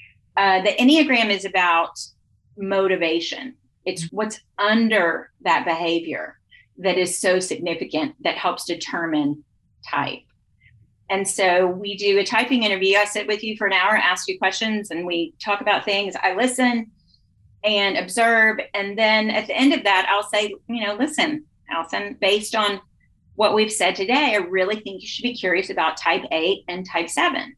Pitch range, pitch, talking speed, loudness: 170-215 Hz, 195 Hz, 170 wpm, -20 LUFS